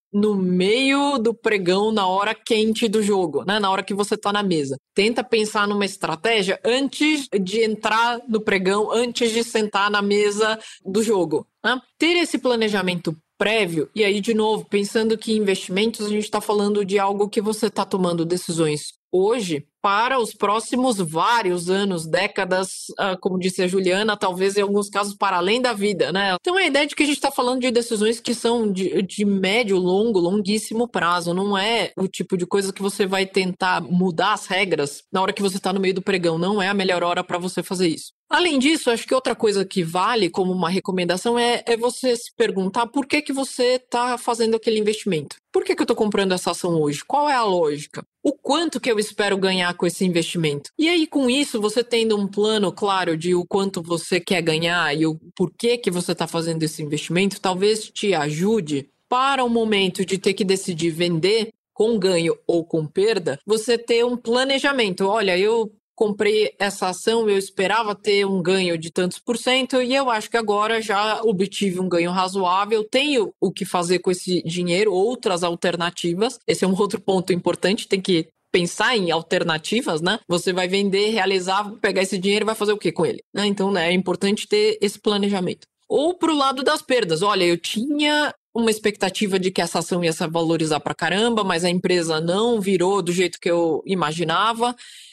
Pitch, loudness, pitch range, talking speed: 200 Hz, -21 LUFS, 185-225 Hz, 195 wpm